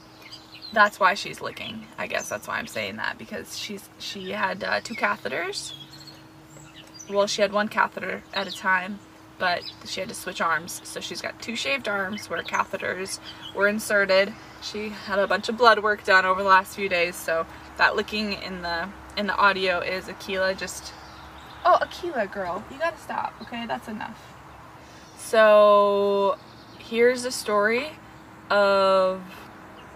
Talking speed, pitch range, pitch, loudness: 160 wpm, 185-210 Hz, 200 Hz, -24 LUFS